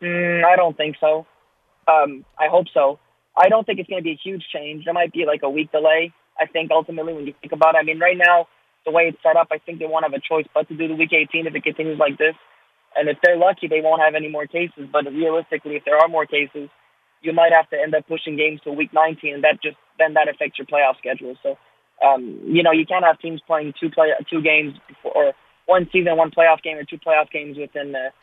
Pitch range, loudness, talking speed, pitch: 150-165 Hz, -19 LUFS, 265 wpm, 160 Hz